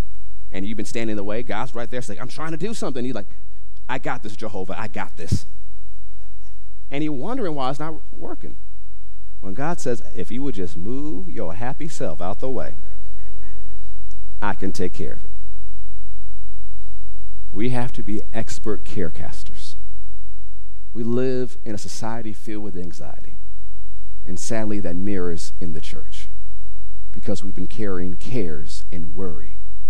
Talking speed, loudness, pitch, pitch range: 160 wpm, -30 LUFS, 95 Hz, 95-110 Hz